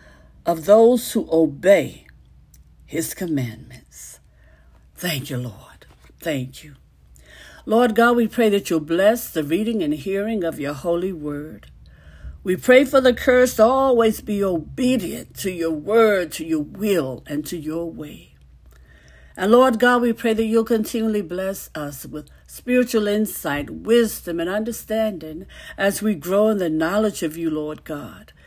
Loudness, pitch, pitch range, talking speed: -20 LUFS, 170 Hz, 130-220 Hz, 150 wpm